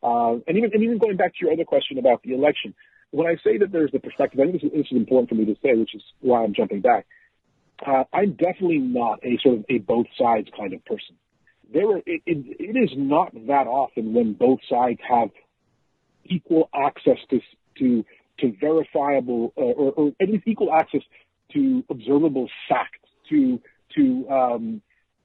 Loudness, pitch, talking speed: -22 LUFS, 160 Hz, 195 wpm